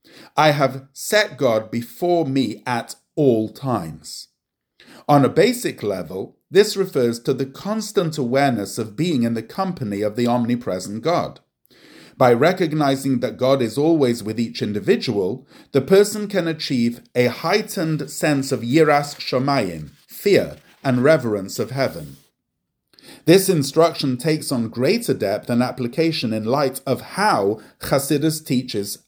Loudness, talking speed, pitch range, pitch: -20 LUFS, 135 wpm, 120-160 Hz, 135 Hz